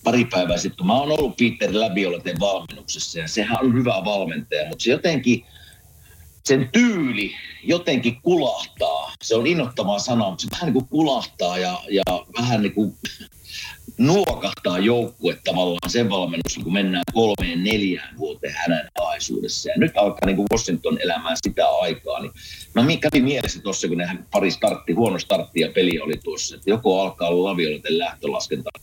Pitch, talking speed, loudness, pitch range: 110 Hz, 160 wpm, -21 LUFS, 90-125 Hz